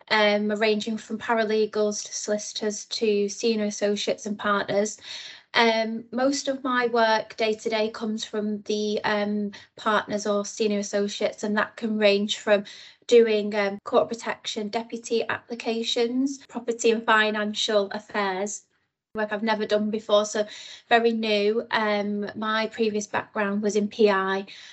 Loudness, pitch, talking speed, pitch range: -25 LUFS, 215 Hz, 140 wpm, 210-225 Hz